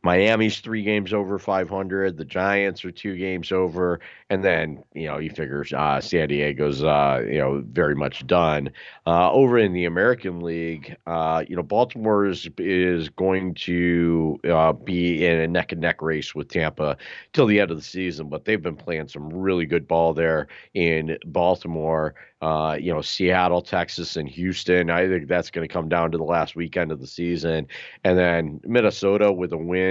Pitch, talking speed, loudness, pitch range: 85 Hz, 190 wpm, -23 LUFS, 80-95 Hz